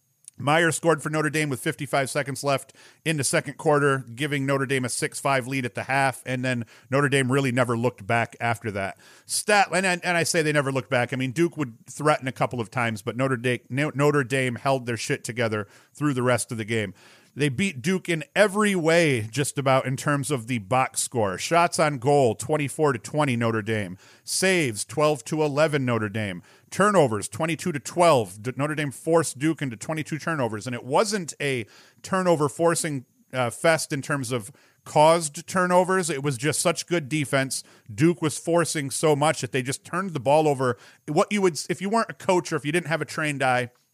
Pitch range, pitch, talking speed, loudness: 125-160 Hz, 145 Hz, 200 wpm, -24 LUFS